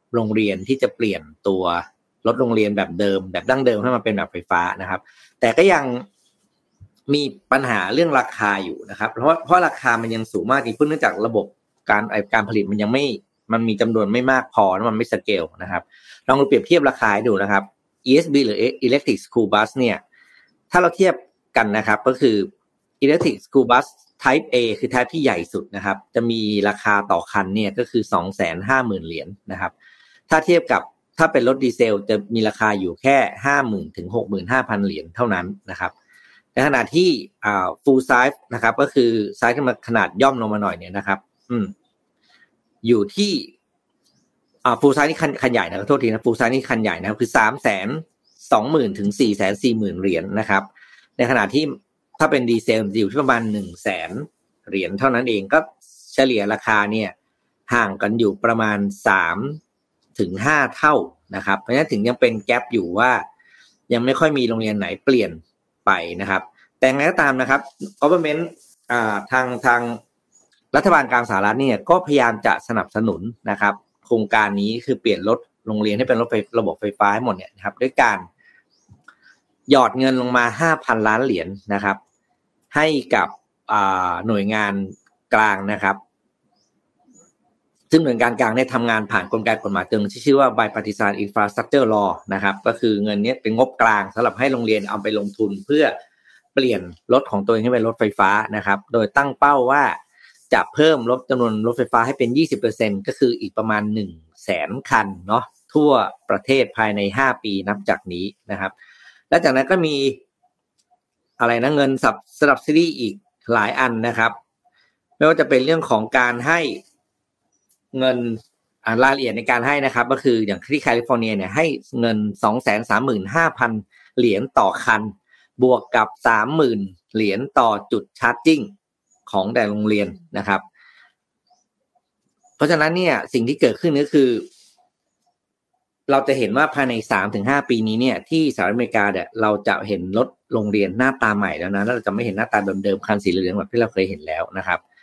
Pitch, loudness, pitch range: 115 Hz, -19 LUFS, 105-135 Hz